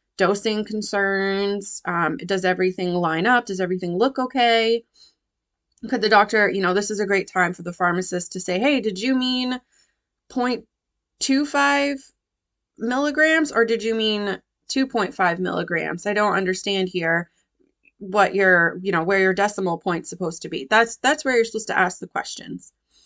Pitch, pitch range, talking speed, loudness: 205 Hz, 185-250 Hz, 165 wpm, -21 LUFS